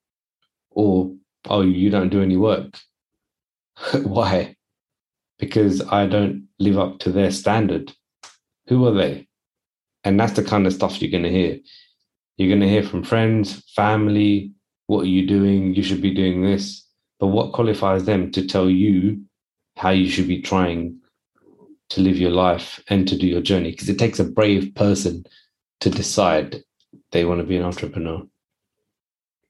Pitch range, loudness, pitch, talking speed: 95-100 Hz, -20 LUFS, 95 Hz, 165 wpm